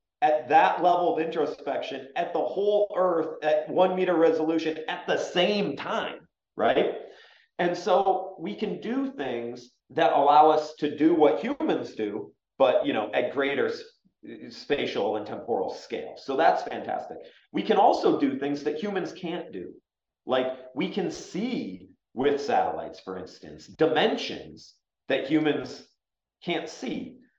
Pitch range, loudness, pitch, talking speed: 155-255 Hz, -26 LUFS, 175 Hz, 145 wpm